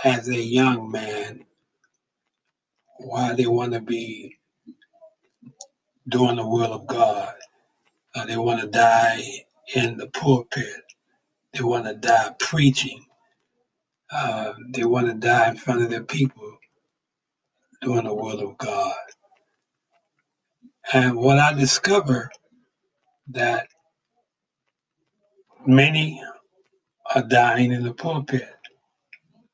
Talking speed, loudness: 110 wpm, -21 LUFS